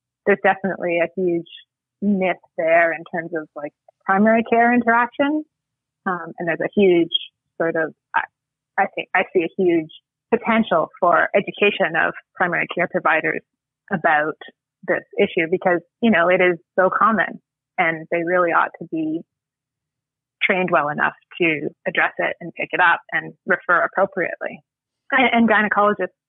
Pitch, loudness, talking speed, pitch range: 180 Hz, -19 LUFS, 150 wpm, 165-205 Hz